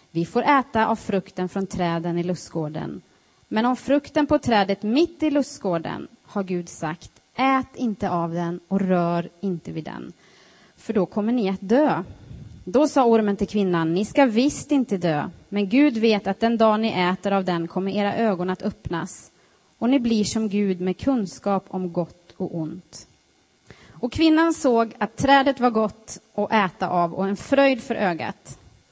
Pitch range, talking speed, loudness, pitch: 180-240 Hz, 180 wpm, -23 LUFS, 205 Hz